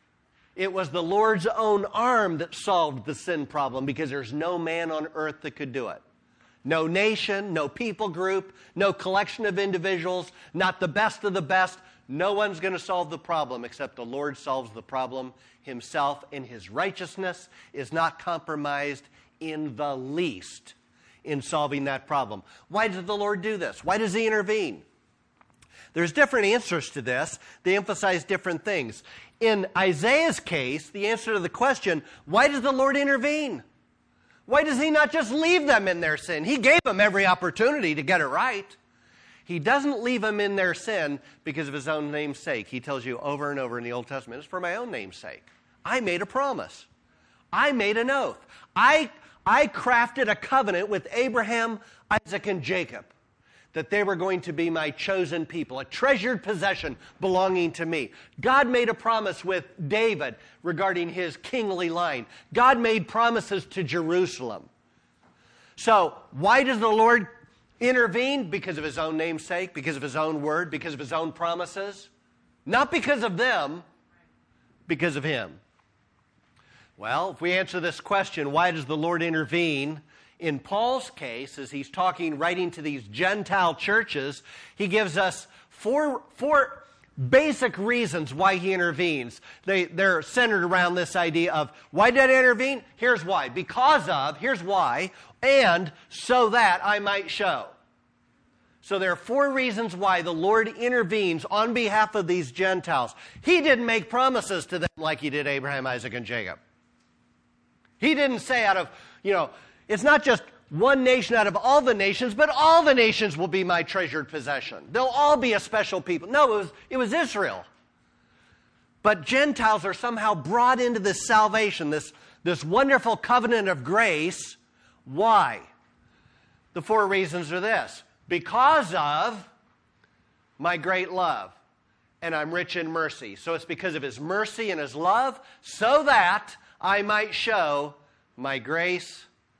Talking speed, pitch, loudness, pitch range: 165 wpm, 185 Hz, -25 LUFS, 155-225 Hz